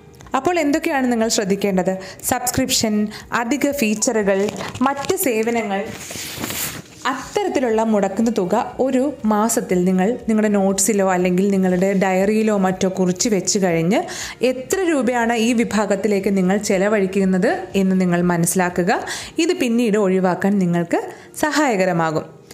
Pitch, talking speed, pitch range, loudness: 210 Hz, 100 wpm, 190-245 Hz, -19 LUFS